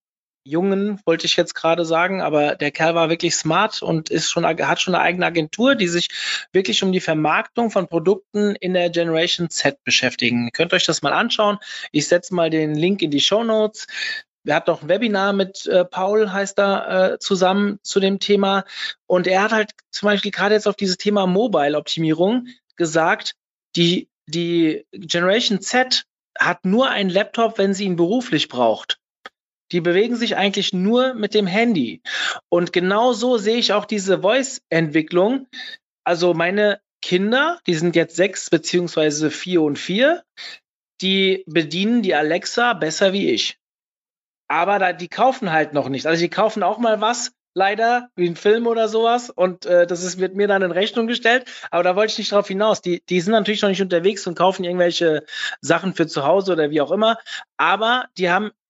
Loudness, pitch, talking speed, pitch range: -19 LUFS, 190 Hz, 185 wpm, 170-210 Hz